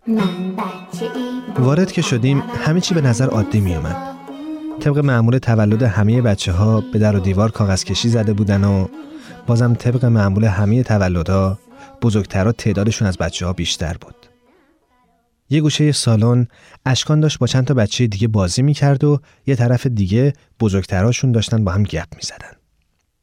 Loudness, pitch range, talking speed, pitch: -17 LUFS, 105-145 Hz, 160 wpm, 120 Hz